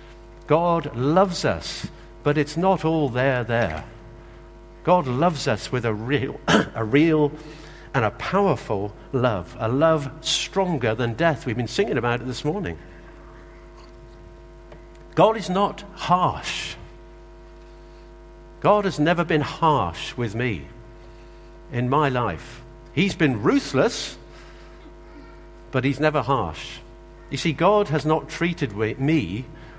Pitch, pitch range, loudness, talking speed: 145 Hz, 120-165 Hz, -23 LUFS, 125 wpm